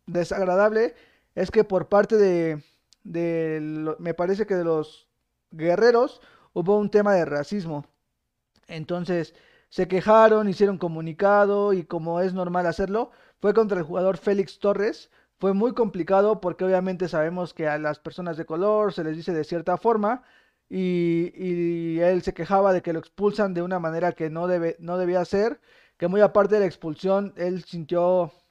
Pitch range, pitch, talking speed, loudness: 170-200 Hz, 180 Hz, 165 wpm, -24 LUFS